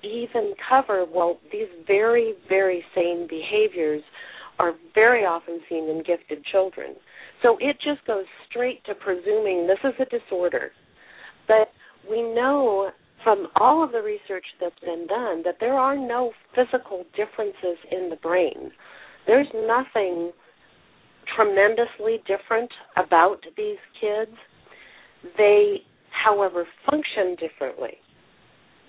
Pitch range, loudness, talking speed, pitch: 180-240 Hz, -23 LUFS, 120 wpm, 210 Hz